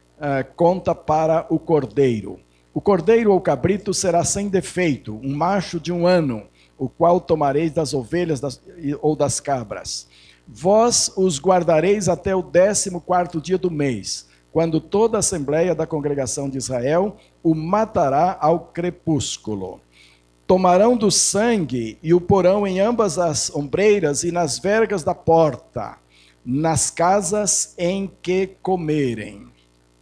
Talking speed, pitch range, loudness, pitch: 135 wpm, 135-185 Hz, -19 LUFS, 165 Hz